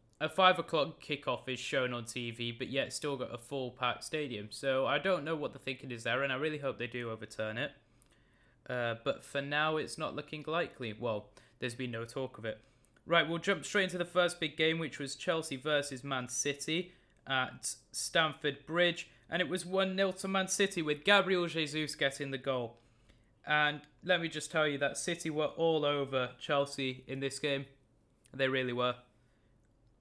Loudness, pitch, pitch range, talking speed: -34 LUFS, 140 Hz, 125-160 Hz, 195 wpm